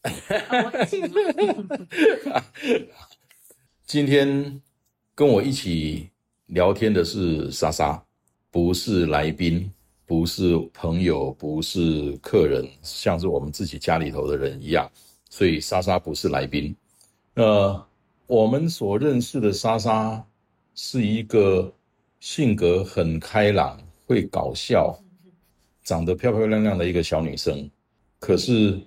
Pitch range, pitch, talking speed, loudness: 85-120 Hz, 100 Hz, 175 characters per minute, -23 LUFS